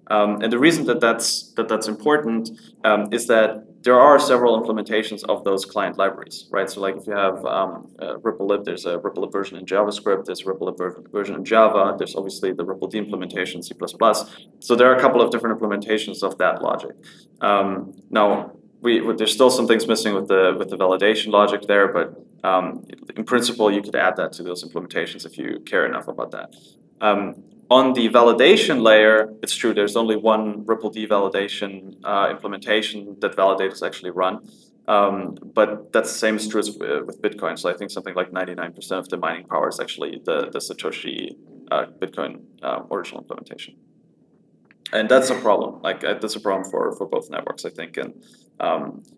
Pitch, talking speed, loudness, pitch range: 110 Hz, 200 wpm, -20 LUFS, 100-120 Hz